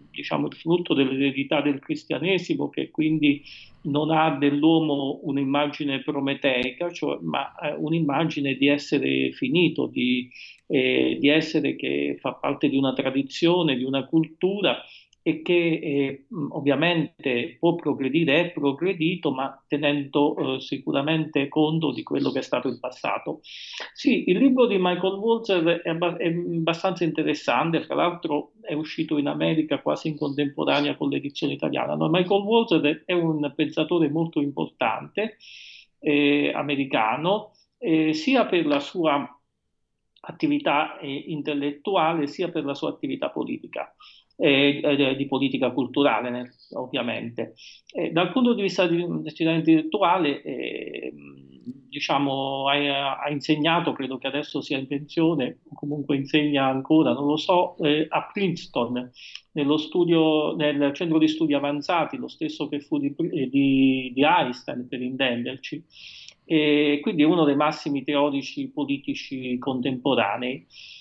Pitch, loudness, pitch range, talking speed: 150 Hz, -24 LUFS, 140-165 Hz, 135 wpm